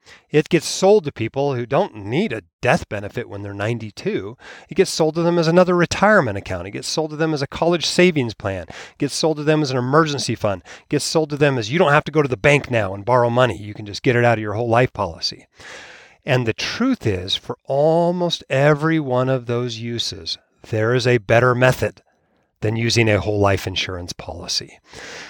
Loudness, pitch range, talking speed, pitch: -19 LUFS, 110-155 Hz, 225 wpm, 125 Hz